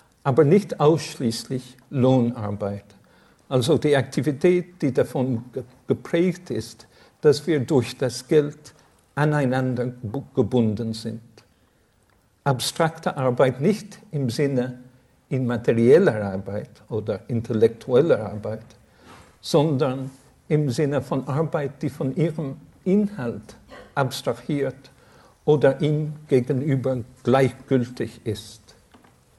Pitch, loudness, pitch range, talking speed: 130 Hz, -23 LUFS, 115-150 Hz, 90 wpm